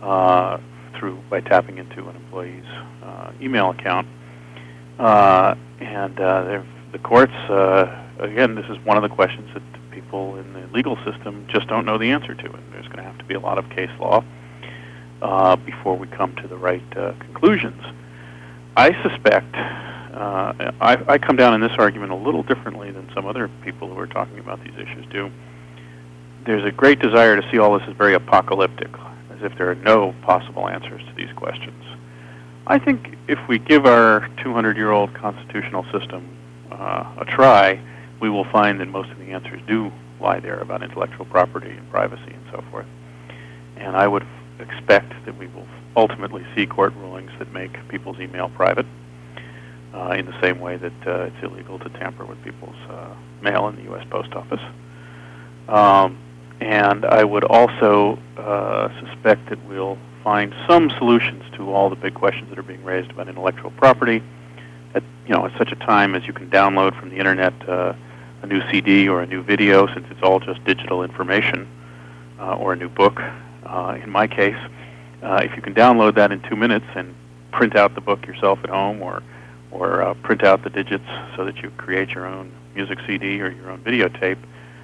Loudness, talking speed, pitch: -18 LUFS, 190 wpm, 90 Hz